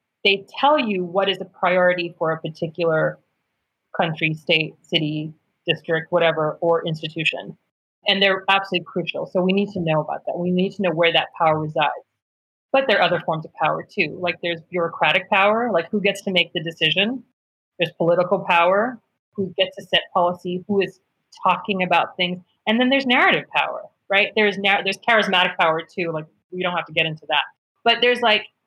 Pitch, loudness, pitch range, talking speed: 180 Hz, -20 LUFS, 165-195 Hz, 190 wpm